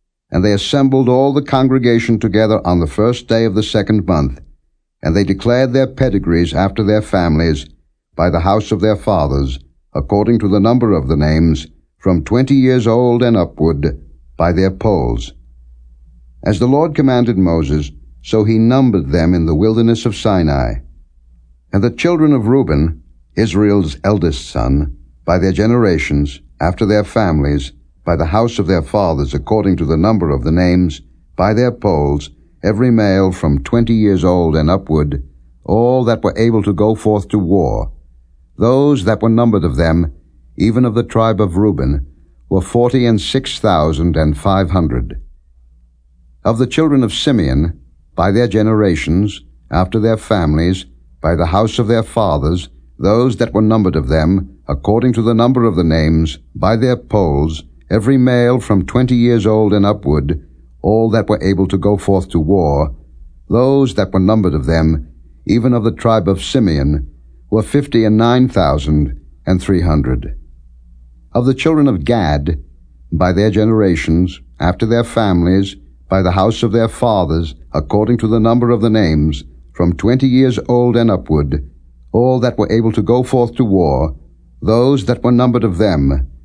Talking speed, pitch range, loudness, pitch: 165 wpm, 75-115 Hz, -14 LUFS, 95 Hz